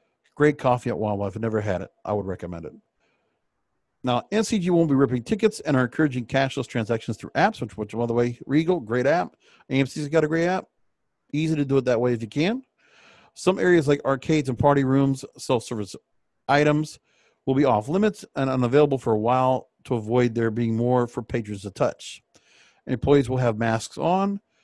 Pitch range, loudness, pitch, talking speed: 115-150 Hz, -23 LUFS, 130 Hz, 195 wpm